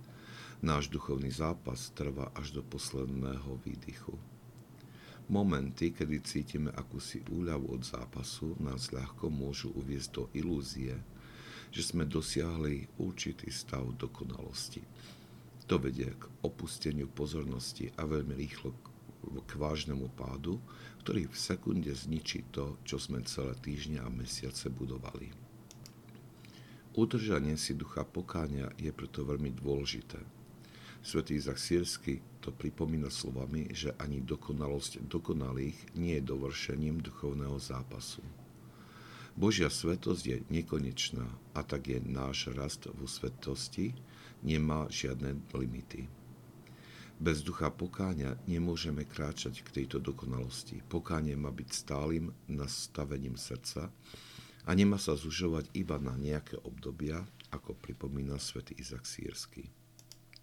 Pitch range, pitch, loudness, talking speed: 65-75 Hz, 70 Hz, -38 LUFS, 115 wpm